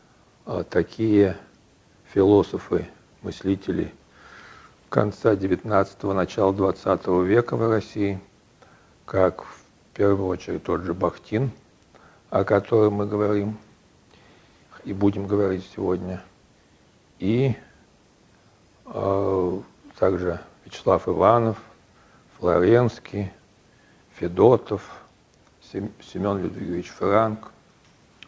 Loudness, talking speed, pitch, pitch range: -23 LUFS, 75 wpm, 100 Hz, 95-110 Hz